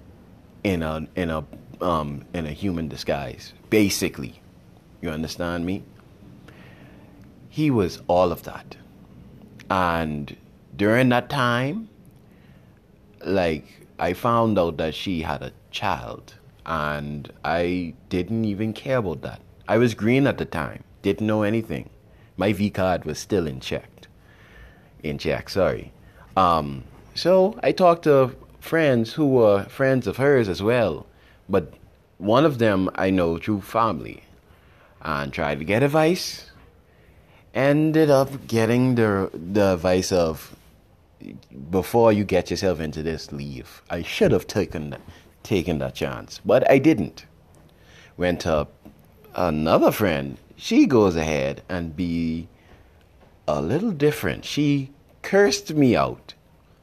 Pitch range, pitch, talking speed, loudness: 80-120 Hz, 95 Hz, 130 wpm, -22 LUFS